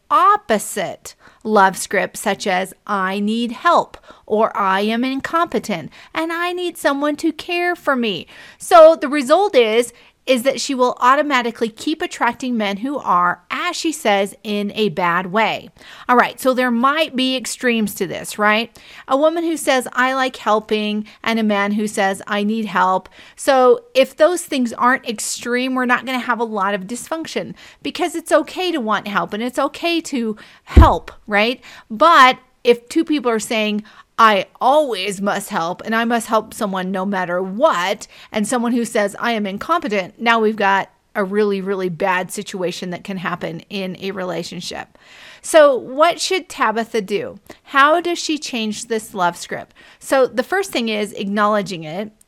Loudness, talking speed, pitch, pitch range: -18 LUFS, 170 wpm, 230 Hz, 205-270 Hz